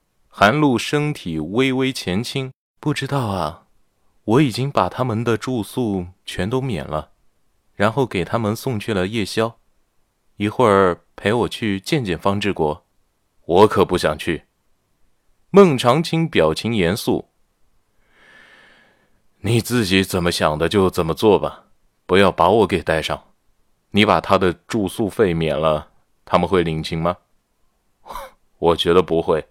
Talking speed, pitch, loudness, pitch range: 195 characters per minute, 100 Hz, -19 LUFS, 90-125 Hz